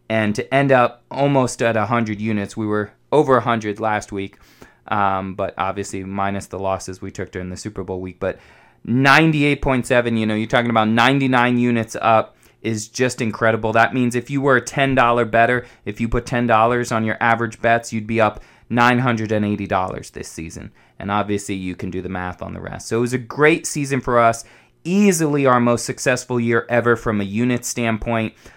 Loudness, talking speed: -19 LUFS, 190 wpm